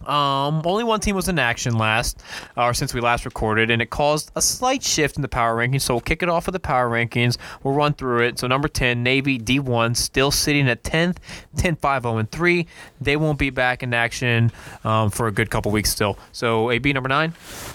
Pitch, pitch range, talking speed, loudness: 130 Hz, 120-150 Hz, 215 wpm, -20 LUFS